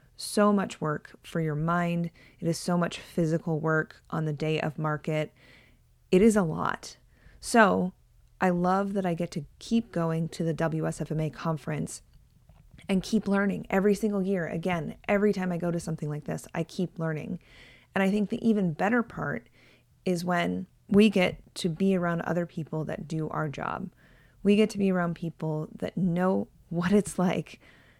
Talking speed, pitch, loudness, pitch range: 180 wpm, 170 Hz, -28 LUFS, 155-195 Hz